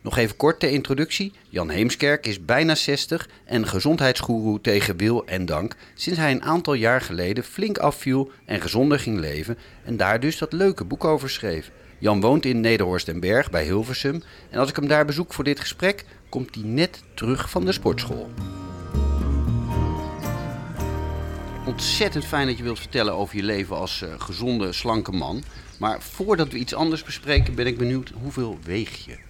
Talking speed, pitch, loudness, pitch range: 175 wpm, 120 Hz, -23 LUFS, 95-145 Hz